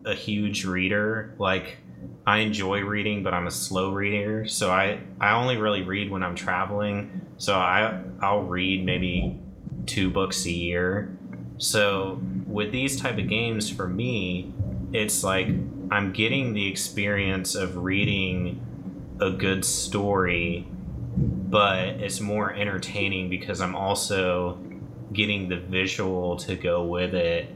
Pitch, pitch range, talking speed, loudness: 95 Hz, 90-105 Hz, 135 wpm, -25 LUFS